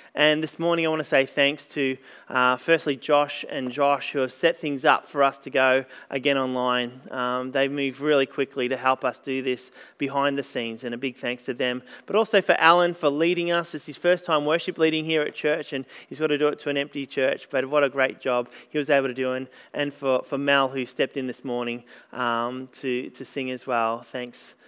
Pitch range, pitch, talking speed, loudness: 130-150 Hz, 140 Hz, 235 wpm, -24 LUFS